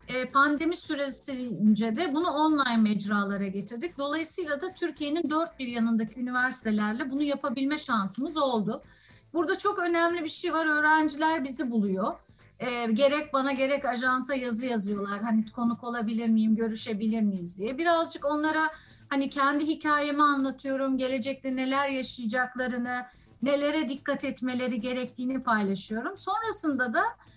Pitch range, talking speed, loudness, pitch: 235-300 Hz, 125 wpm, -28 LUFS, 270 Hz